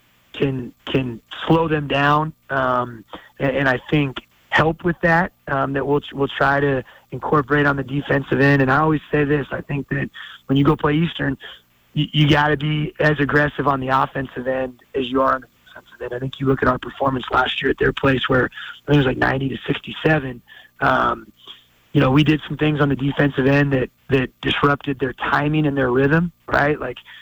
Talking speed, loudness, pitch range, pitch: 215 wpm, -19 LUFS, 130-150 Hz, 140 Hz